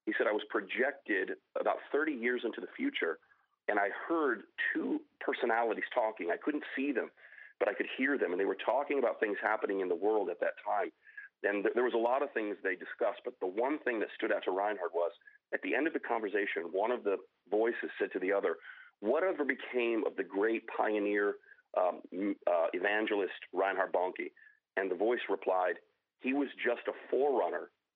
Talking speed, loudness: 200 wpm, -34 LUFS